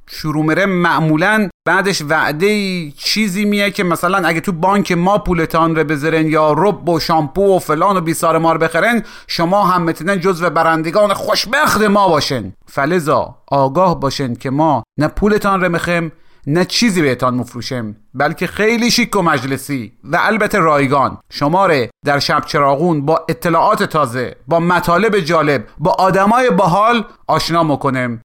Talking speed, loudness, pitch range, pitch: 155 wpm, -14 LUFS, 150-195 Hz, 165 Hz